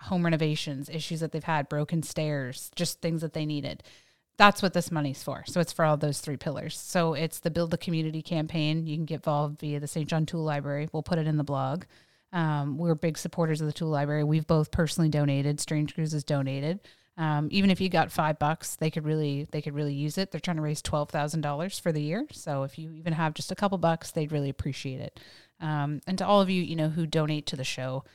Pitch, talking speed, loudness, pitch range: 155 Hz, 240 wpm, -29 LUFS, 150-165 Hz